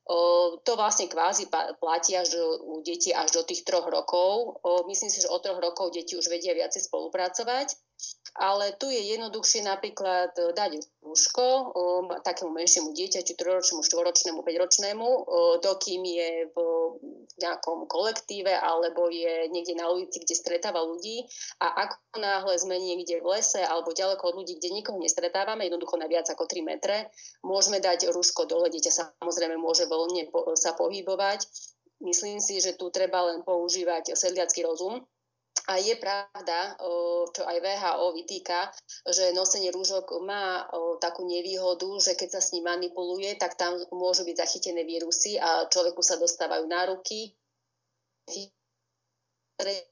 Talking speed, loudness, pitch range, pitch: 150 wpm, -27 LUFS, 170-195 Hz, 180 Hz